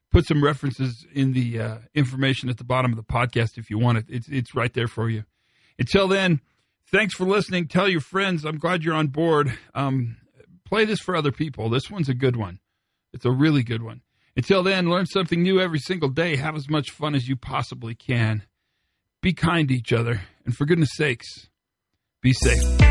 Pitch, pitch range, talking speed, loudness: 135 Hz, 120-165 Hz, 205 wpm, -23 LUFS